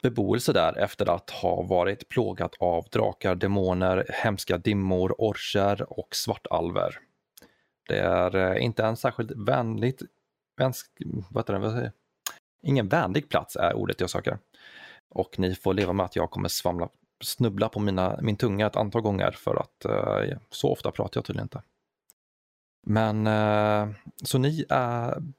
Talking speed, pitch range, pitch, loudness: 140 wpm, 95-120 Hz, 105 Hz, -27 LUFS